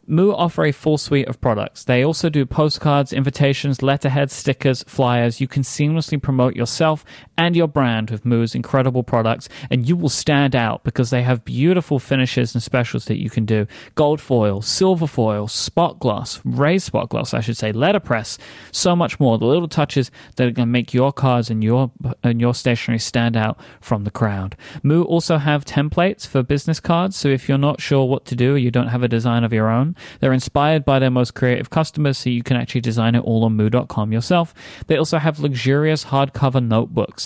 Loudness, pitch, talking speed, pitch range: -19 LUFS, 130 Hz, 200 wpm, 120-150 Hz